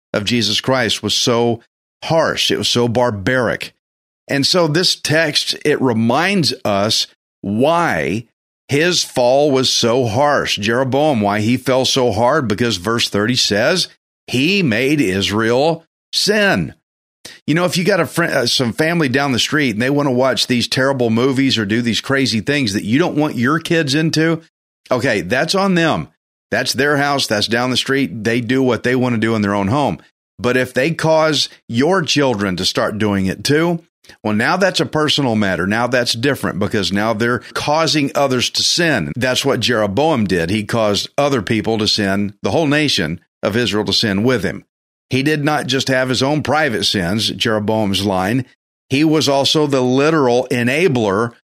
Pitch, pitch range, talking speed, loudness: 125 Hz, 110-145 Hz, 180 wpm, -16 LUFS